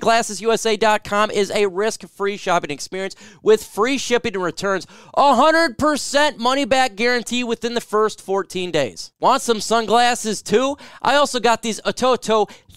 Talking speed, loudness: 135 wpm, -19 LUFS